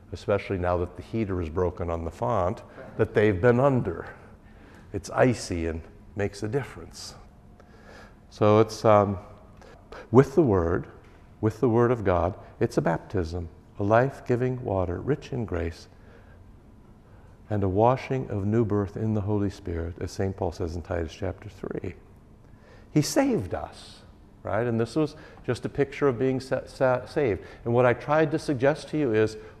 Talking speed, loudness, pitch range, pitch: 170 wpm, -26 LUFS, 95-120 Hz, 105 Hz